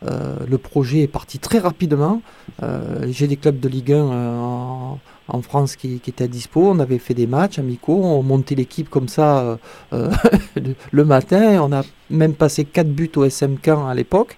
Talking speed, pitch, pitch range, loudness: 195 wpm, 140 Hz, 130-155 Hz, -18 LUFS